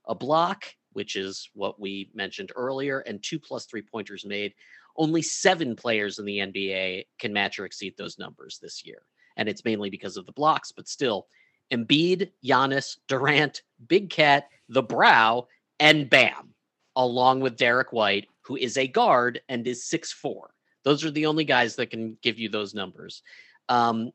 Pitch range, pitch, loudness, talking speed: 110-145 Hz, 125 Hz, -24 LUFS, 175 wpm